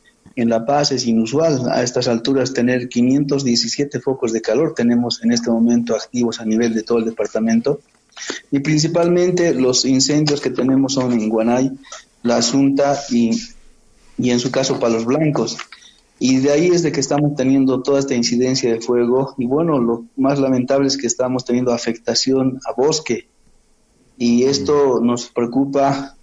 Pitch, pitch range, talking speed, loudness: 130 Hz, 120-140 Hz, 160 wpm, -17 LUFS